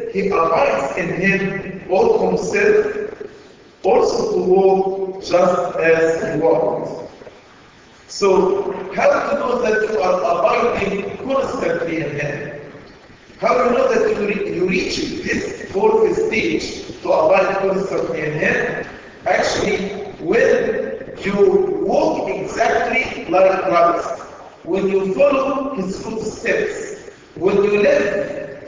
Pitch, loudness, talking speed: 220 Hz, -18 LUFS, 120 wpm